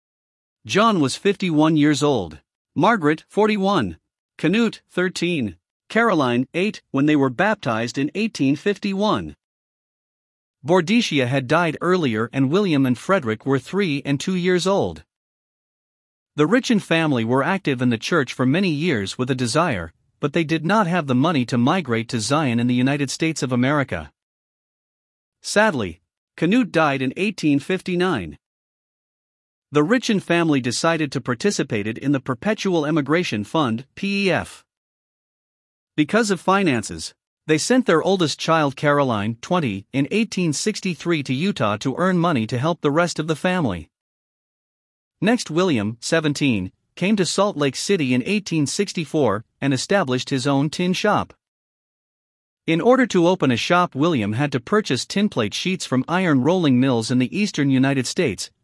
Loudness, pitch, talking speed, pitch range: -20 LUFS, 150 Hz, 145 wpm, 130-185 Hz